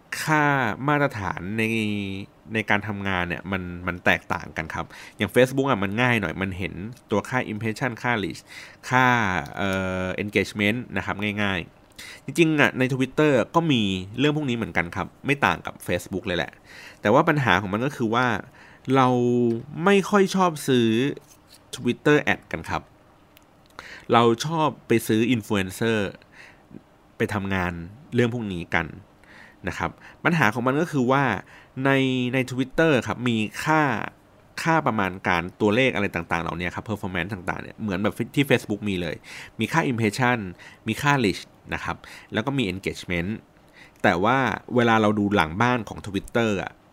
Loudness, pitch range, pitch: -23 LUFS, 95-130 Hz, 110 Hz